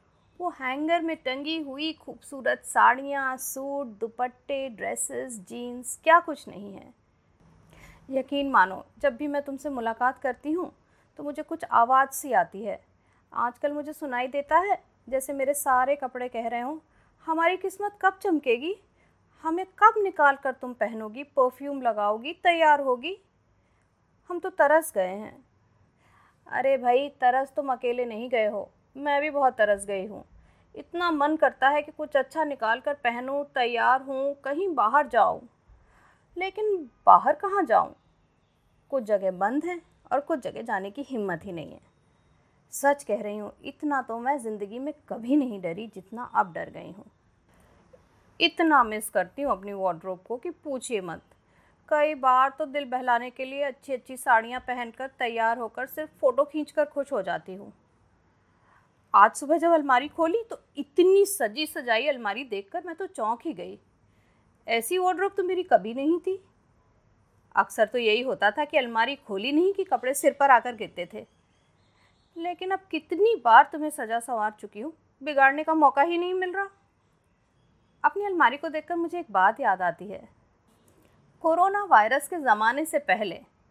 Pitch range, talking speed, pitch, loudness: 240-320 Hz, 165 wpm, 280 Hz, -26 LUFS